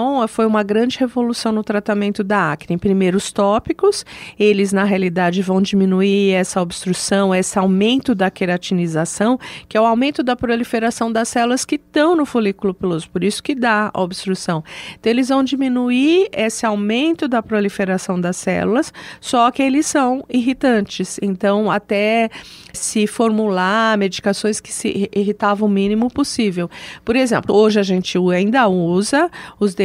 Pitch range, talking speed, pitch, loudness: 195-240 Hz, 150 wpm, 210 Hz, -17 LUFS